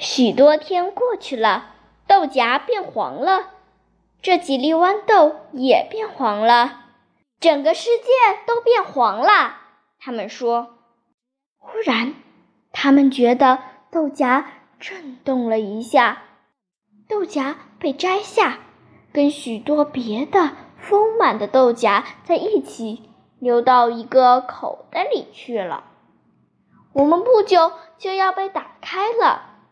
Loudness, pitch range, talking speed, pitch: -18 LUFS, 245-380 Hz, 165 characters per minute, 290 Hz